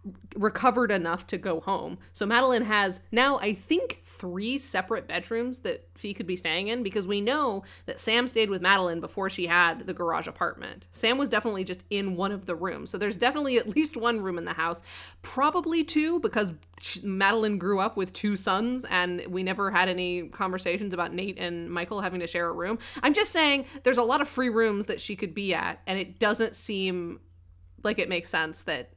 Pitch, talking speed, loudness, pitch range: 200 Hz, 210 wpm, -27 LUFS, 180-235 Hz